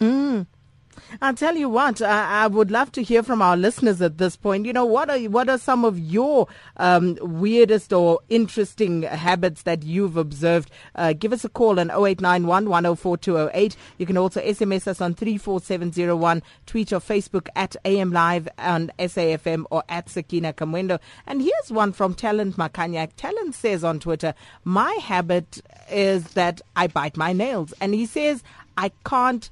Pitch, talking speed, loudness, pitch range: 190 Hz, 185 wpm, -22 LUFS, 170-220 Hz